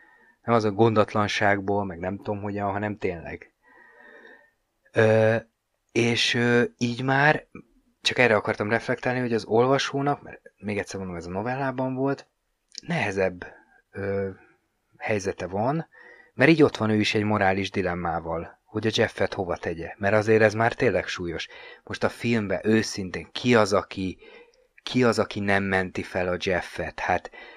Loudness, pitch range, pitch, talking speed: -25 LUFS, 100-120 Hz, 110 Hz, 150 wpm